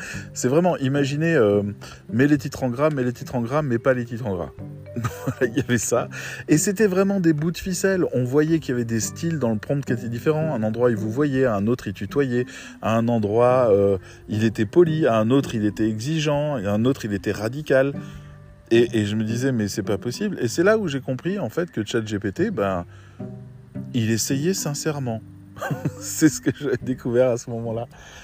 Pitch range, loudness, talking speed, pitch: 110-150 Hz, -22 LUFS, 220 wpm, 125 Hz